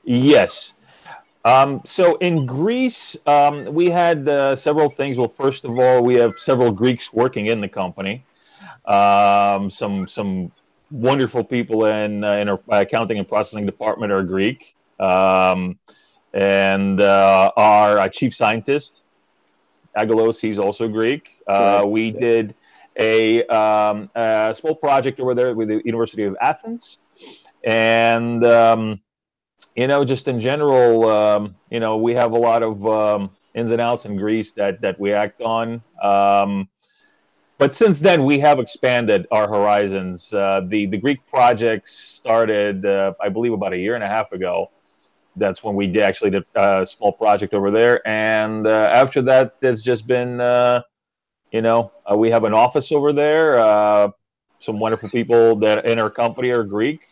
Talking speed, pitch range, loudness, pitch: 160 wpm, 105-125 Hz, -17 LUFS, 115 Hz